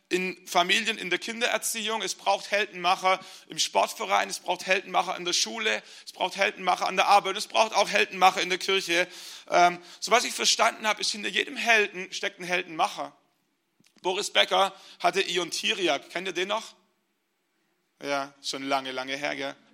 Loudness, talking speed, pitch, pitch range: -26 LUFS, 170 wpm, 185 Hz, 175-200 Hz